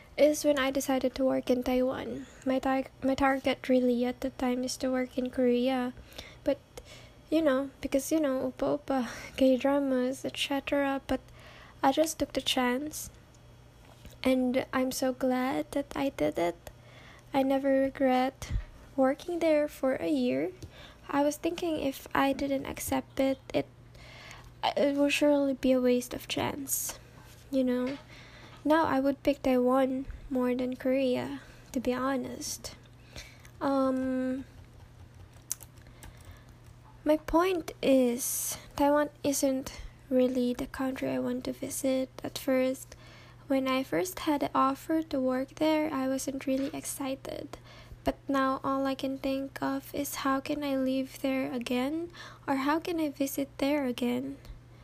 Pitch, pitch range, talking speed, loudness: 265 Hz, 255-280 Hz, 145 wpm, -30 LUFS